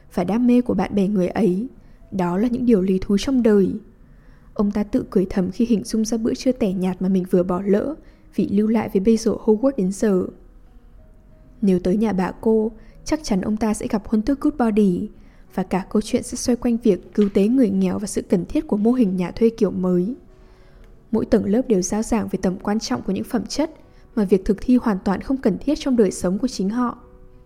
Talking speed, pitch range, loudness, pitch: 240 wpm, 190-235 Hz, -21 LUFS, 215 Hz